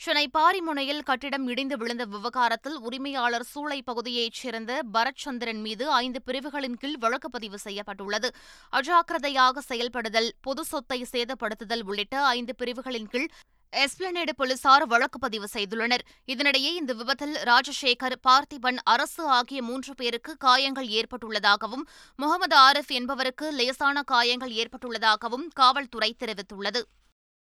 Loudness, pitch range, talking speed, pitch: -26 LUFS, 235-280 Hz, 110 wpm, 255 Hz